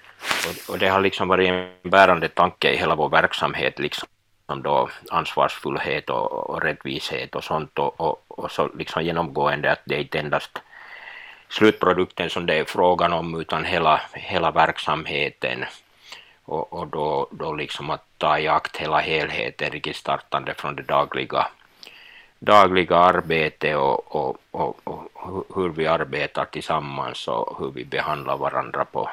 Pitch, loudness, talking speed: 90 Hz, -22 LUFS, 145 wpm